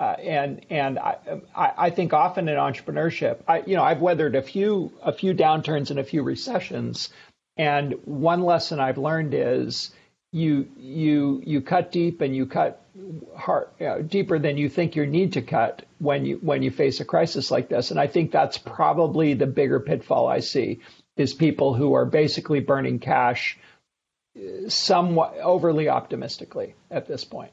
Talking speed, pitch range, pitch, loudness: 175 wpm, 140-175 Hz, 155 Hz, -23 LUFS